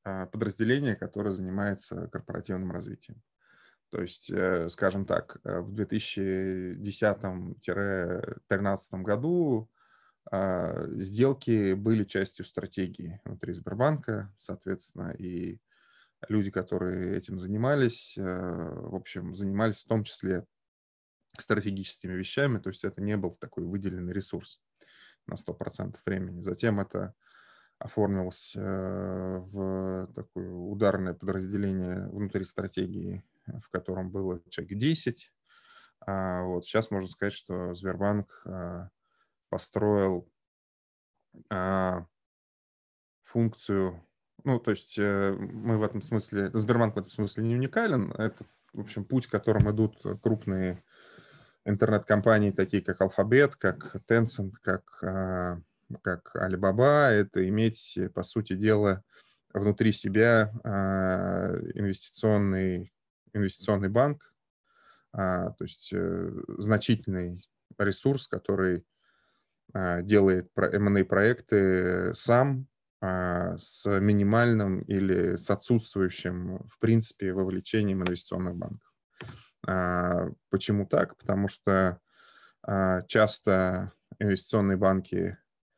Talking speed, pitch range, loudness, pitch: 90 wpm, 95-105 Hz, -29 LUFS, 95 Hz